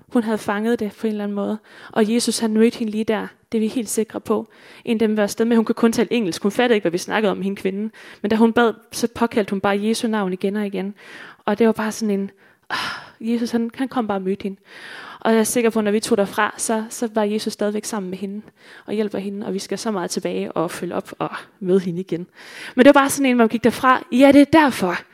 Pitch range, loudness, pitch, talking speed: 205-235 Hz, -20 LUFS, 220 Hz, 280 wpm